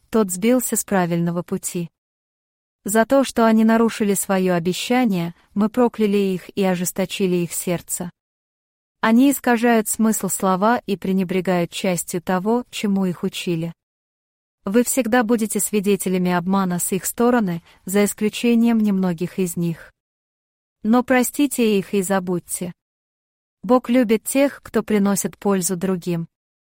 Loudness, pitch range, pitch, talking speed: -20 LUFS, 180-225 Hz, 200 Hz, 125 wpm